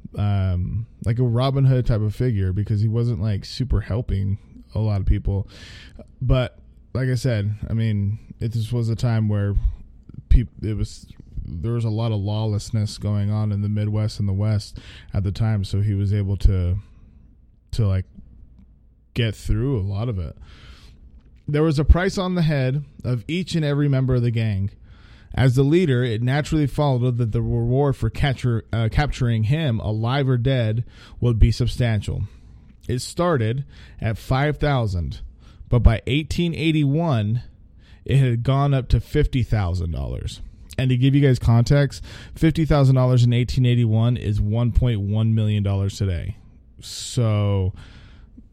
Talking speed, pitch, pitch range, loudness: 165 wpm, 110 Hz, 100-125 Hz, -22 LUFS